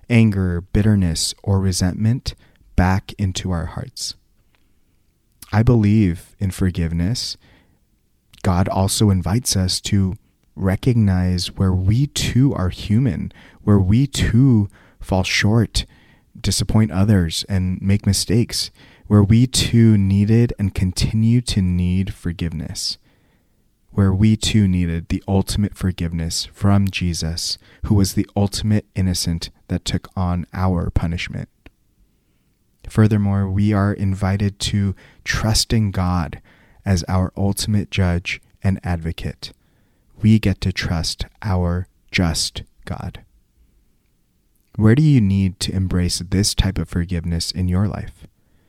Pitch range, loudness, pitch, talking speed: 90-105 Hz, -19 LUFS, 95 Hz, 115 wpm